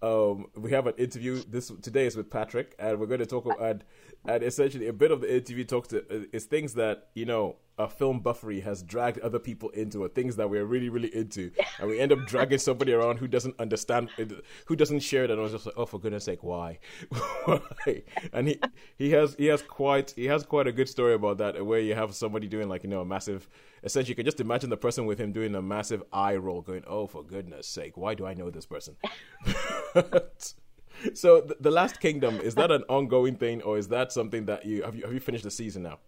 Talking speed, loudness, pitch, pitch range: 240 wpm, -29 LUFS, 115 Hz, 105-130 Hz